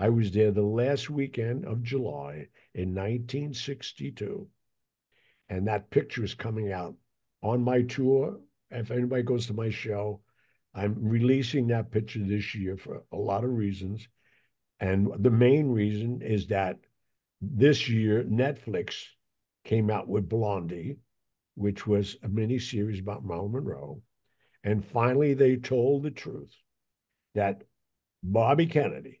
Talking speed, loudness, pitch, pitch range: 140 wpm, -28 LUFS, 110 Hz, 105-125 Hz